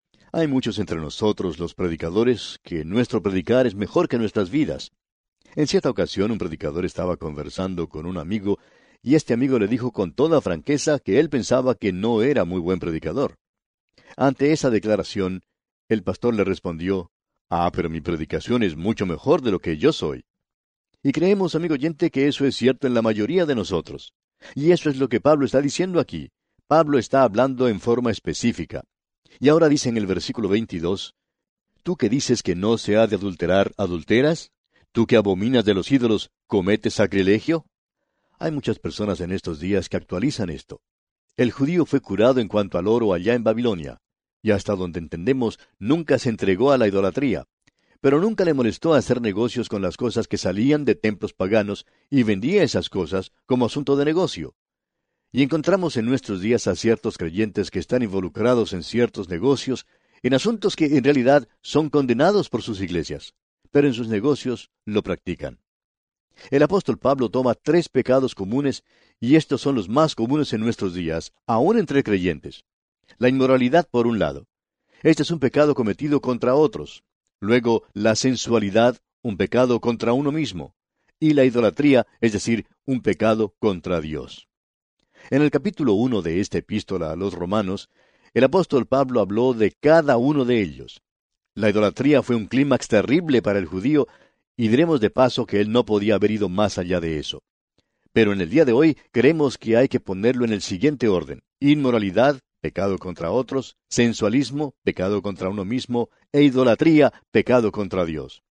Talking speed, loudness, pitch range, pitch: 175 wpm, -21 LUFS, 95-135 Hz, 115 Hz